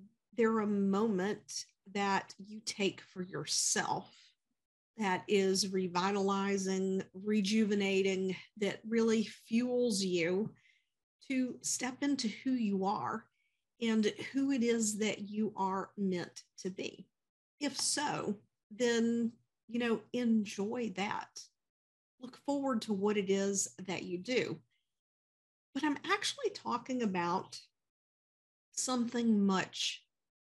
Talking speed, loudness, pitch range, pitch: 110 wpm, -34 LUFS, 195-235 Hz, 210 Hz